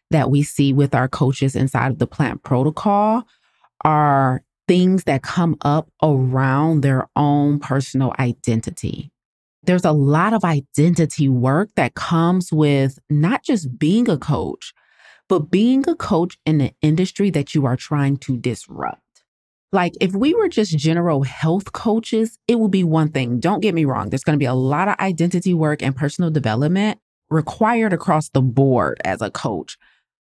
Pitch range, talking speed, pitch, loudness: 135-185 Hz, 165 wpm, 155 Hz, -18 LUFS